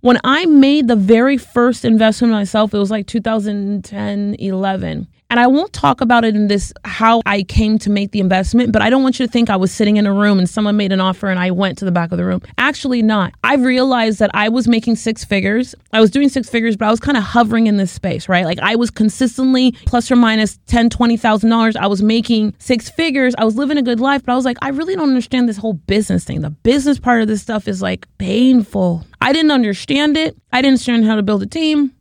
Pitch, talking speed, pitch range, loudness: 225 Hz, 255 wpm, 205-250 Hz, -14 LUFS